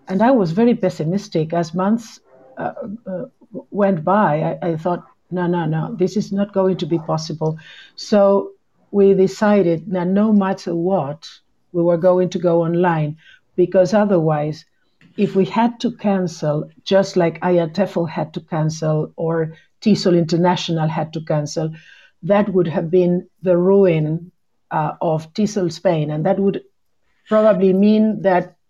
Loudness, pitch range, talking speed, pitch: -18 LUFS, 165-200 Hz, 150 wpm, 180 Hz